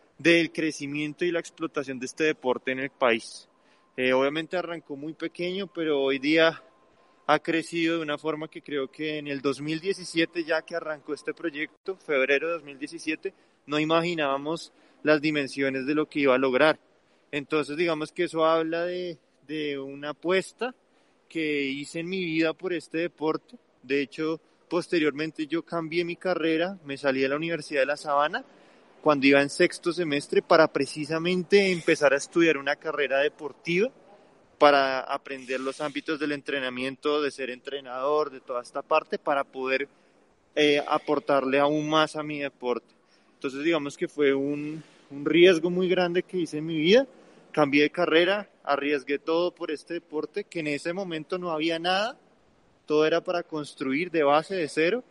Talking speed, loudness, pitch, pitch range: 165 wpm, -26 LUFS, 155 Hz, 140-170 Hz